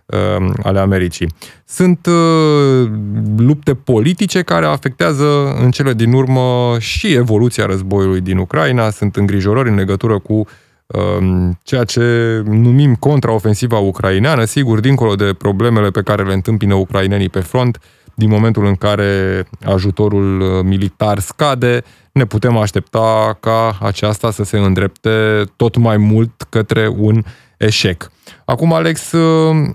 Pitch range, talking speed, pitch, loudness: 100-125 Hz, 125 wpm, 110 Hz, -13 LUFS